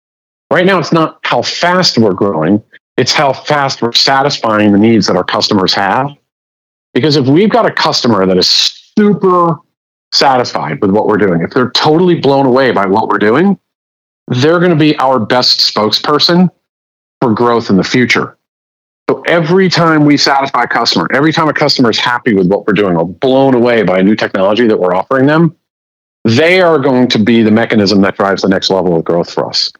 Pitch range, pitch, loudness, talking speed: 100-160 Hz, 125 Hz, -10 LUFS, 195 wpm